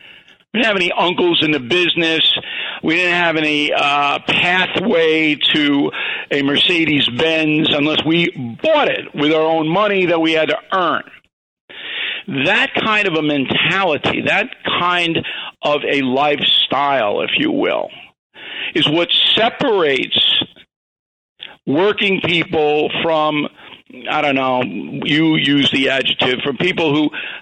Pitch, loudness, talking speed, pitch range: 160 Hz, -15 LUFS, 130 wpm, 150-175 Hz